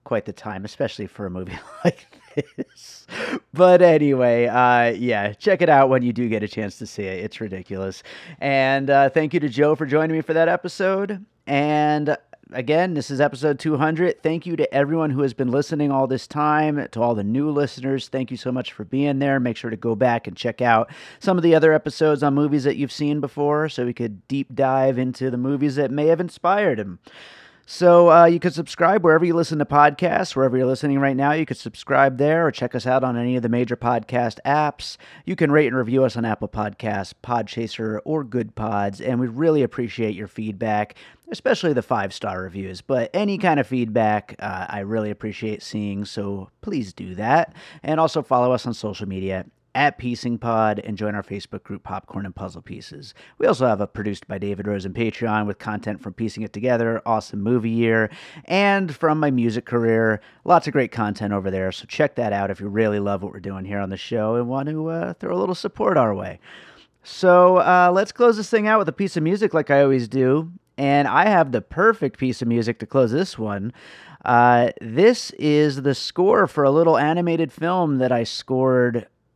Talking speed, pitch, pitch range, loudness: 215 wpm, 130 Hz, 110-150 Hz, -20 LUFS